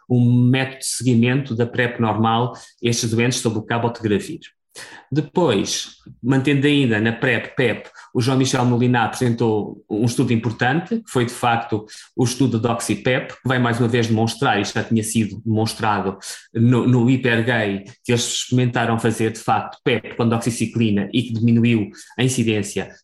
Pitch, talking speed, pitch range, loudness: 120 Hz, 170 wpm, 115-125 Hz, -19 LUFS